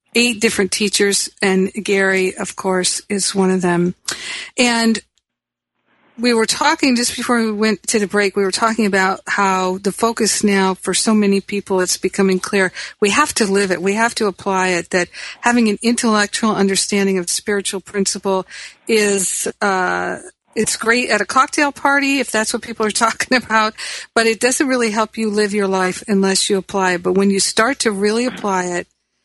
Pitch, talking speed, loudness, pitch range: 205 Hz, 180 wpm, -16 LUFS, 190-230 Hz